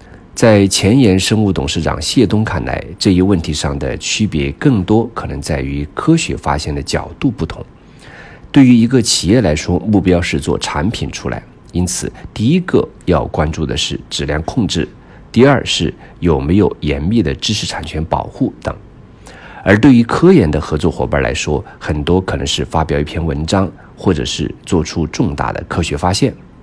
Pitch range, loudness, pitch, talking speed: 75-105 Hz, -14 LUFS, 85 Hz, 260 characters per minute